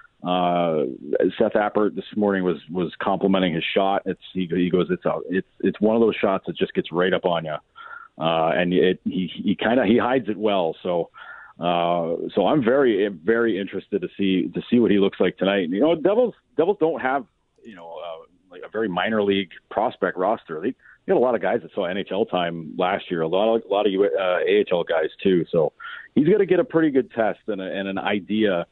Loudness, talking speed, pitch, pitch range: -22 LUFS, 230 wpm, 100 Hz, 90-130 Hz